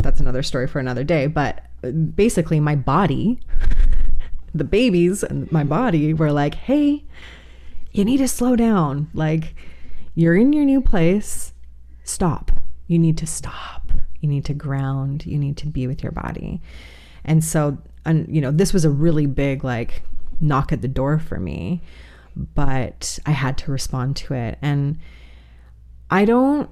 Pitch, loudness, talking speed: 140 Hz, -20 LUFS, 160 wpm